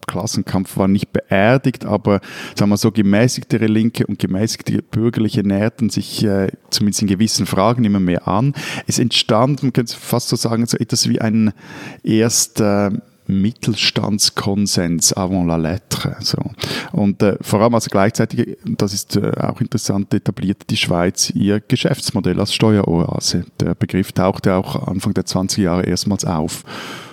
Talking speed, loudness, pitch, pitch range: 155 wpm, -17 LUFS, 105 Hz, 100-115 Hz